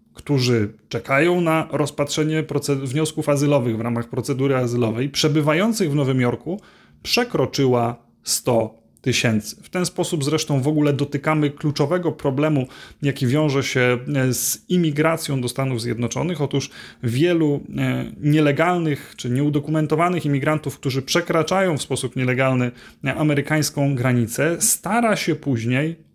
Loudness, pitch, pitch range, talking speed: -21 LUFS, 145 Hz, 130-155 Hz, 120 wpm